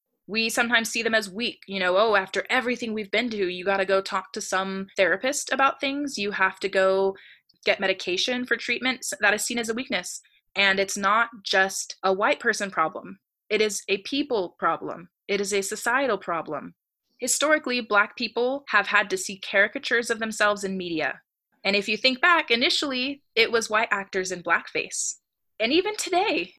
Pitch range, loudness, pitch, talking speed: 195-250 Hz, -24 LUFS, 215 Hz, 185 wpm